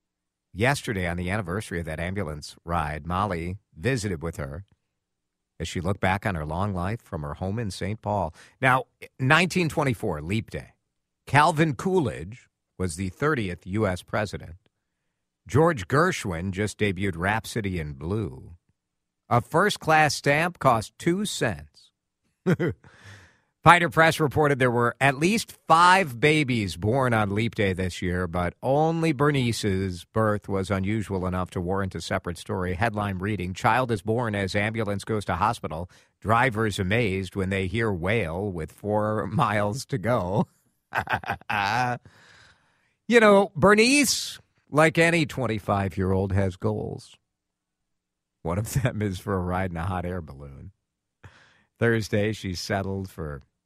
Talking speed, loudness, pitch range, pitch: 140 wpm, -25 LUFS, 90-125 Hz, 105 Hz